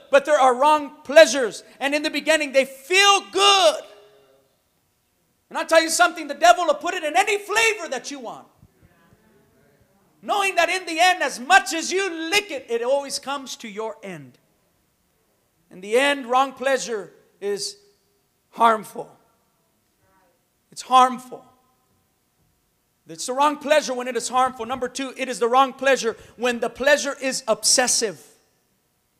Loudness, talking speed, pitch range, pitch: -20 LUFS, 150 wpm, 250-325 Hz, 275 Hz